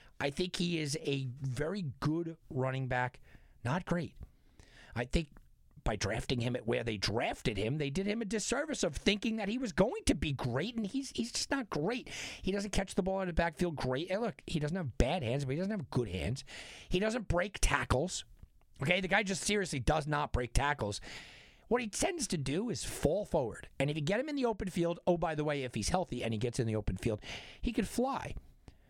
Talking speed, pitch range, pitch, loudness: 225 wpm, 130-200 Hz, 155 Hz, -35 LUFS